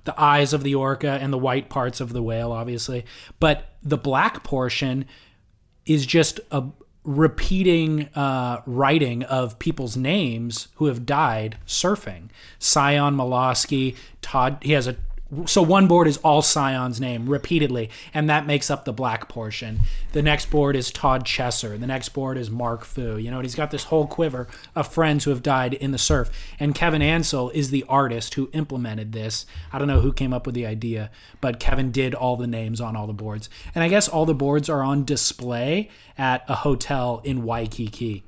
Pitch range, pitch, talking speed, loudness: 120-150 Hz, 130 Hz, 190 wpm, -22 LUFS